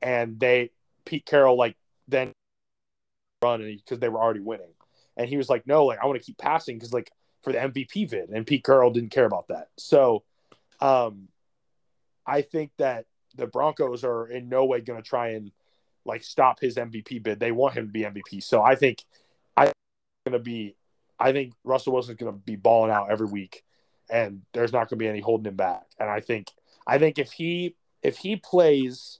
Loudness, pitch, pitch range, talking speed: -25 LUFS, 120 Hz, 110-130 Hz, 210 wpm